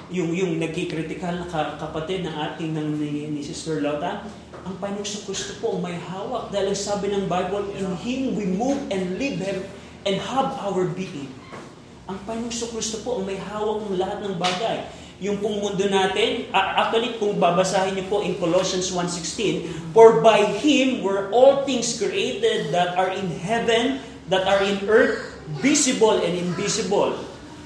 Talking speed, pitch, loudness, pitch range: 170 wpm, 195 Hz, -22 LUFS, 175-220 Hz